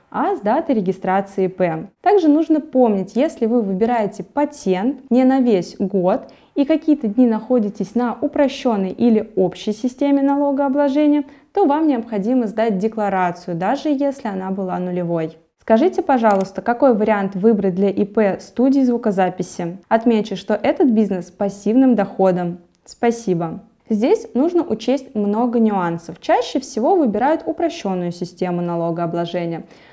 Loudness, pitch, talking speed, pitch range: -18 LUFS, 220 Hz, 130 wpm, 190-275 Hz